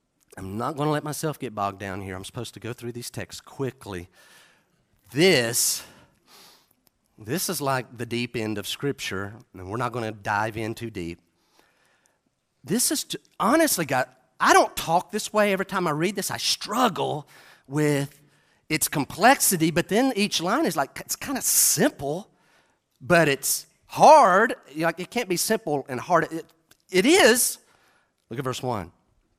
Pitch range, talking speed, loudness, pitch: 115-170 Hz, 170 wpm, -23 LUFS, 135 Hz